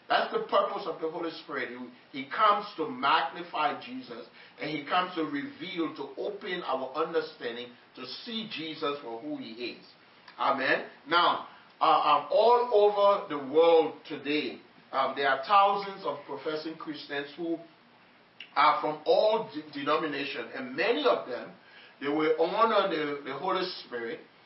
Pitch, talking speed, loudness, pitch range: 160 Hz, 150 wpm, -29 LUFS, 145-200 Hz